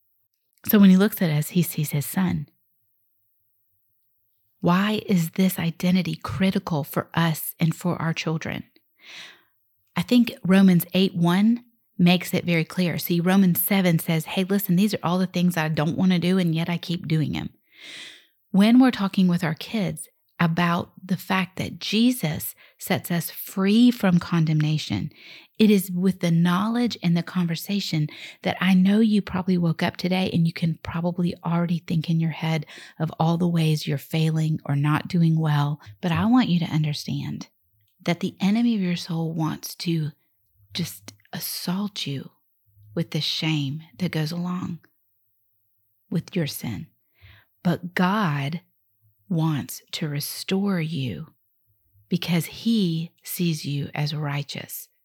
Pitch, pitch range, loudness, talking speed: 170 Hz, 150-185 Hz, -23 LUFS, 155 wpm